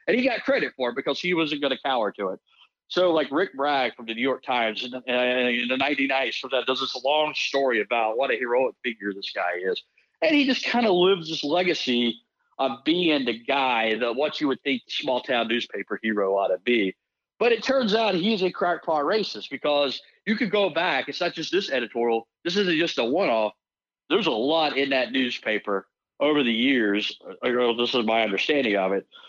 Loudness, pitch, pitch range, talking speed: -24 LUFS, 135 Hz, 120-175 Hz, 215 wpm